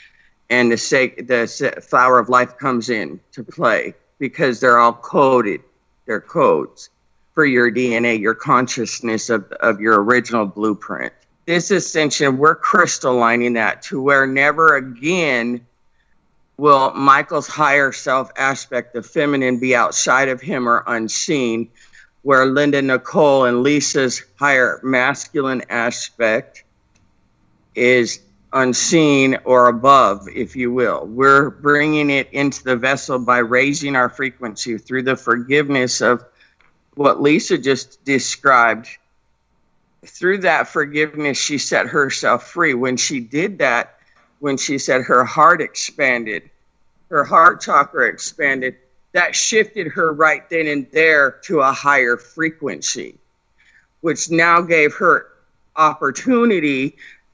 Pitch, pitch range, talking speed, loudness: 130 Hz, 120-145 Hz, 125 wpm, -16 LUFS